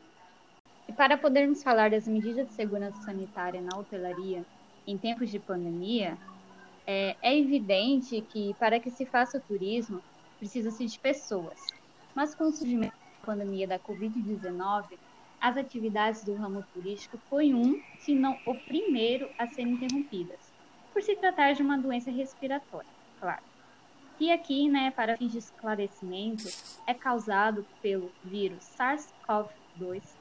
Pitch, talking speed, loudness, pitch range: 225 Hz, 135 wpm, -31 LUFS, 200-270 Hz